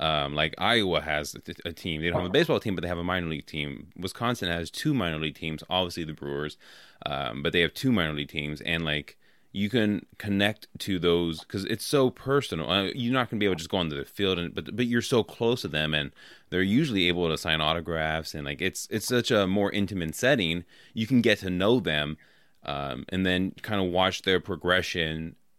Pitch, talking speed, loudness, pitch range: 90 Hz, 235 wpm, -27 LUFS, 80-100 Hz